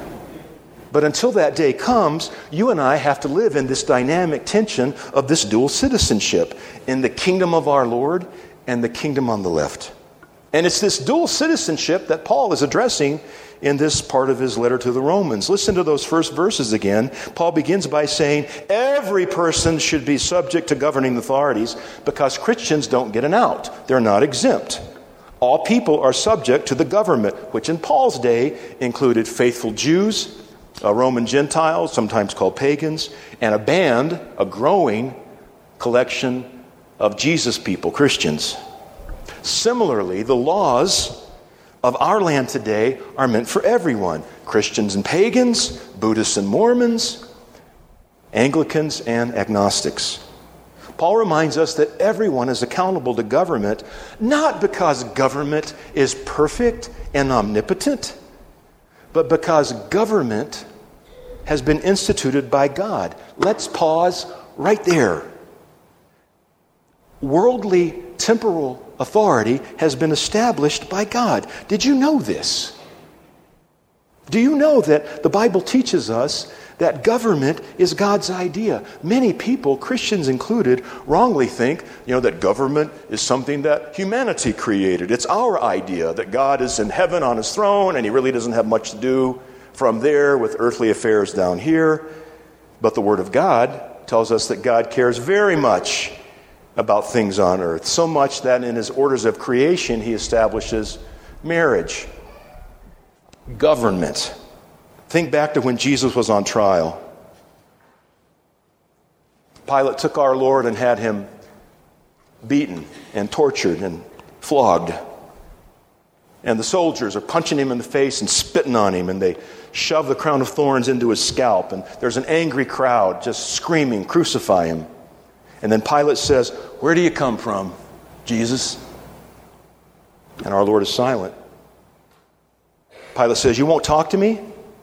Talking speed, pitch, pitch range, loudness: 145 wpm, 150 Hz, 125-190 Hz, -18 LUFS